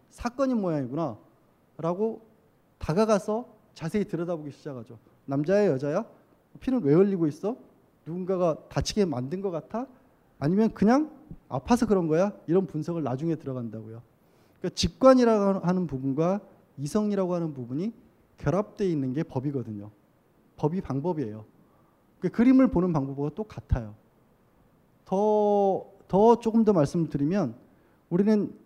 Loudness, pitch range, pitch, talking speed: -26 LUFS, 145-210 Hz, 180 Hz, 320 characters per minute